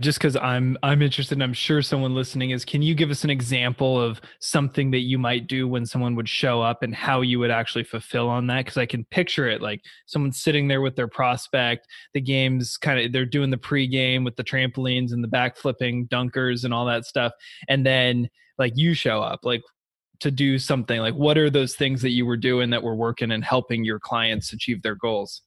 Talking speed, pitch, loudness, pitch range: 230 wpm, 125 Hz, -23 LUFS, 120-135 Hz